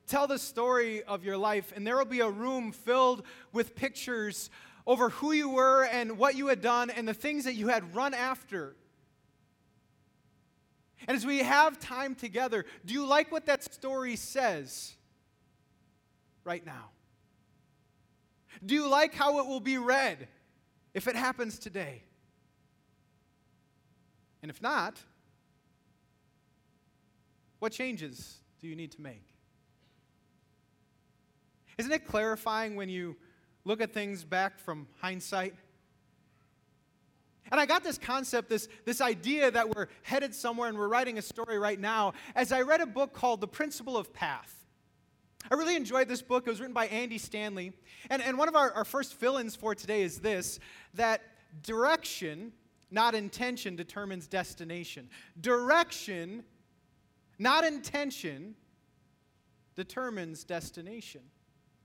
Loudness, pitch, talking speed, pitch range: -31 LUFS, 225 Hz, 140 wpm, 185-260 Hz